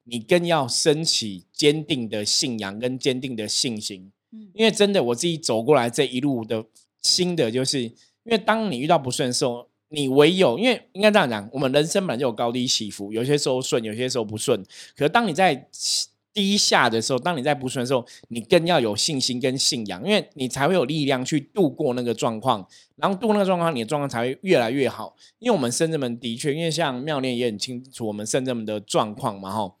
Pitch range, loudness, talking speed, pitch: 120-165 Hz, -22 LUFS, 330 characters per minute, 130 Hz